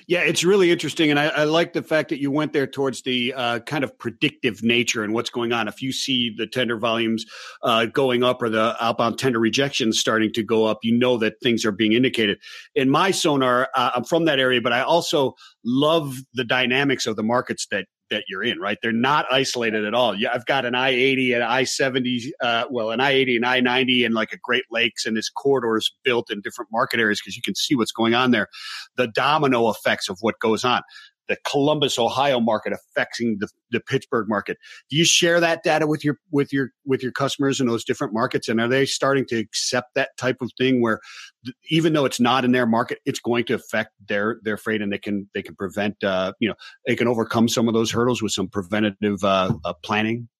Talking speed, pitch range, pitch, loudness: 225 wpm, 115-135 Hz, 125 Hz, -21 LUFS